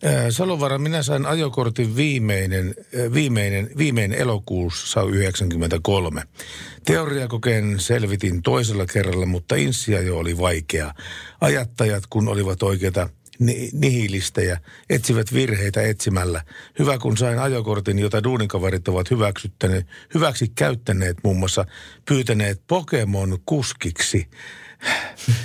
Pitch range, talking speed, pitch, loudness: 95-125 Hz, 95 wpm, 105 Hz, -21 LUFS